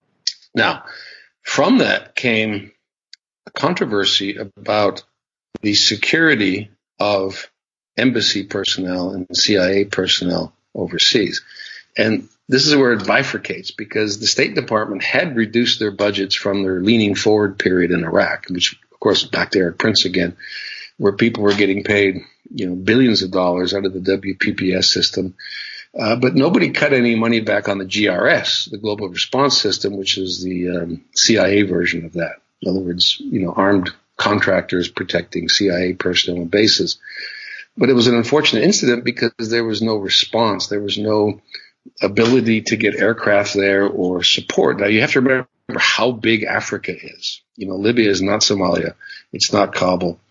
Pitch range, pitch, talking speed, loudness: 95-115 Hz, 105 Hz, 160 wpm, -17 LUFS